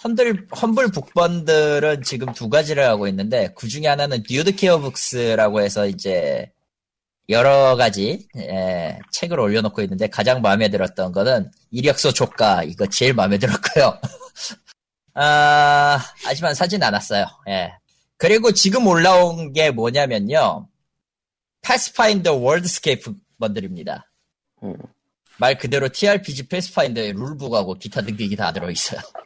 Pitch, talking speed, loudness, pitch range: 145 Hz, 300 characters per minute, -18 LUFS, 120-185 Hz